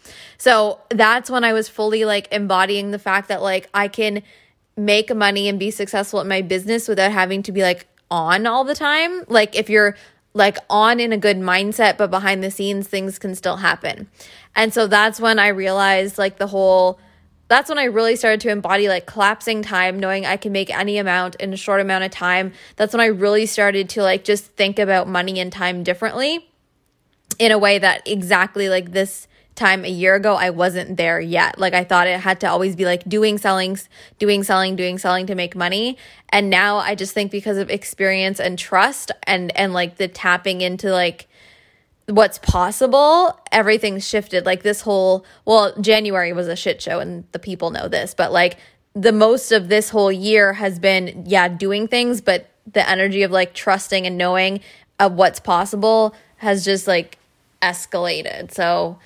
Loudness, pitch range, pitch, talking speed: -17 LUFS, 185-215 Hz, 195 Hz, 195 wpm